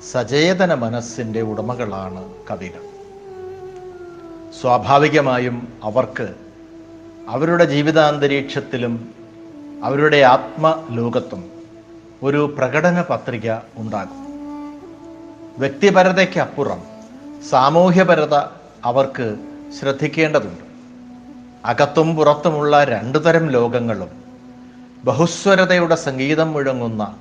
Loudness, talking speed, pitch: -17 LUFS, 55 wpm, 155 Hz